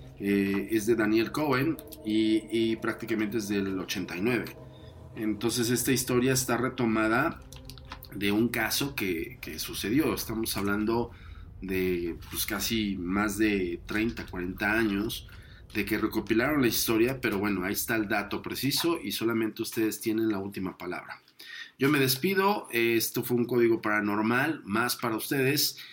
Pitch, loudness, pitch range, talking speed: 110 Hz, -28 LUFS, 100-120 Hz, 145 wpm